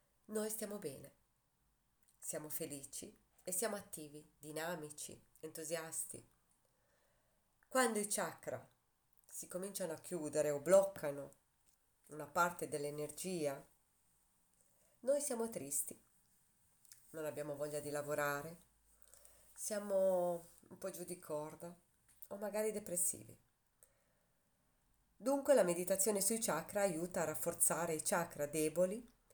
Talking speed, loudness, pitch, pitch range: 100 wpm, -39 LUFS, 170 Hz, 150-195 Hz